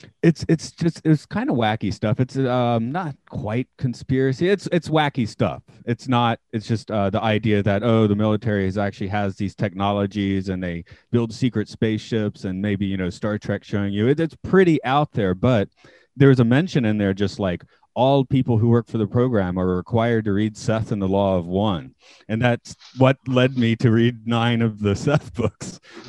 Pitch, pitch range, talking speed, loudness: 115 Hz, 100-130 Hz, 200 wpm, -21 LUFS